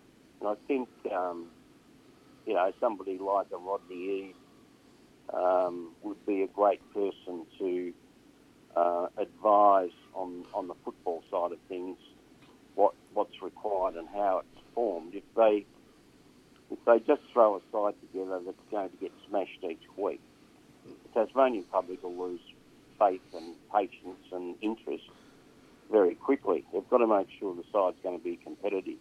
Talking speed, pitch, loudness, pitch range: 155 wpm, 100 Hz, -31 LUFS, 90-115 Hz